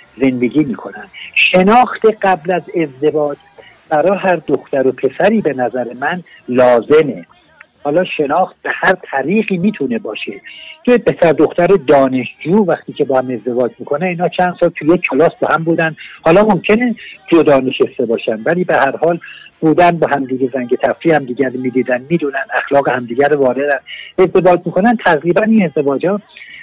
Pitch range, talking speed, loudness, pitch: 135-185 Hz, 155 wpm, -14 LUFS, 160 Hz